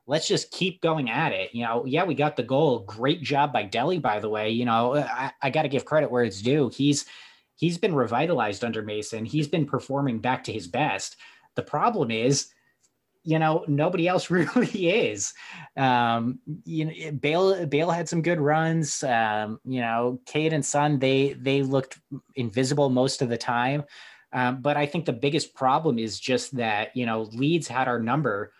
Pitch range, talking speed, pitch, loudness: 120-155 Hz, 195 wpm, 135 Hz, -25 LUFS